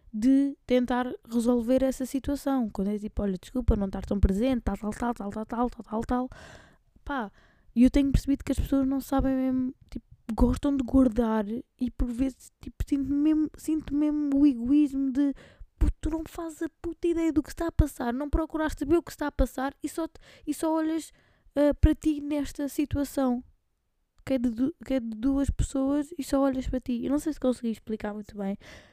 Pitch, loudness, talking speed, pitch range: 270 Hz, -28 LUFS, 210 wpm, 245-290 Hz